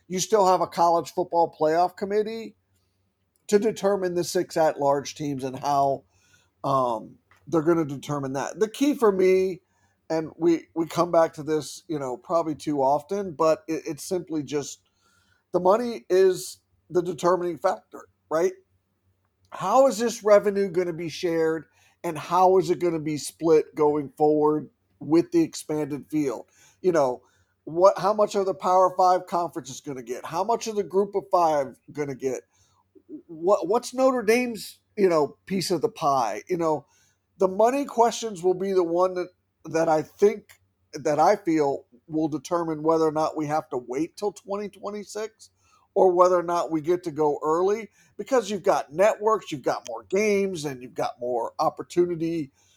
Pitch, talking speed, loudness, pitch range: 170 Hz, 175 wpm, -24 LUFS, 150-195 Hz